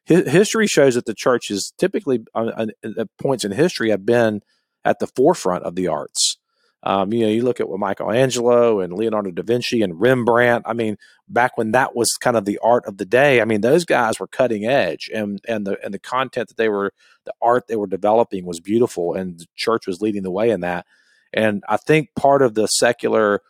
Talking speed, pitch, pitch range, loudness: 220 wpm, 110 Hz, 100-120 Hz, -19 LUFS